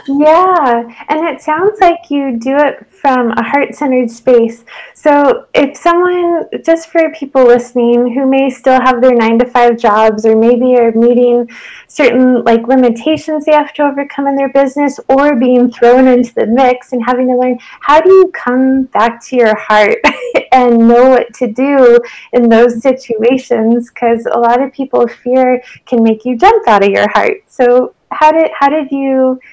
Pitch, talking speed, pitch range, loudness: 255 Hz, 180 wpm, 240-285 Hz, -10 LUFS